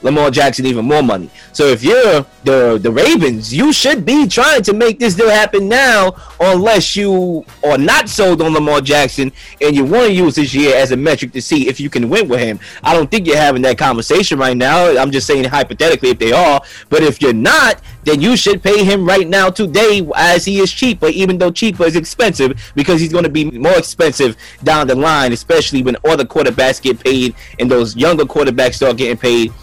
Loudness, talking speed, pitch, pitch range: -12 LUFS, 215 wpm, 155 Hz, 130-200 Hz